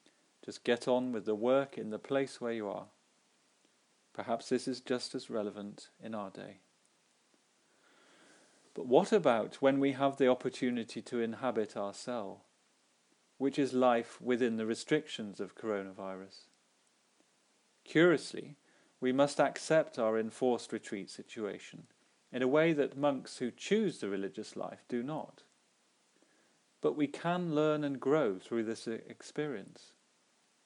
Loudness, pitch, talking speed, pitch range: -34 LUFS, 125 Hz, 135 wpm, 110-140 Hz